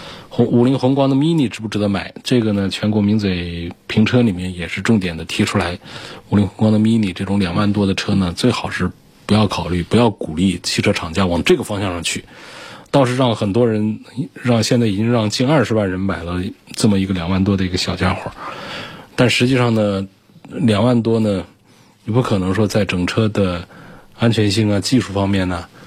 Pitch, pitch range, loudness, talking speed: 105 Hz, 95-115 Hz, -17 LUFS, 305 characters per minute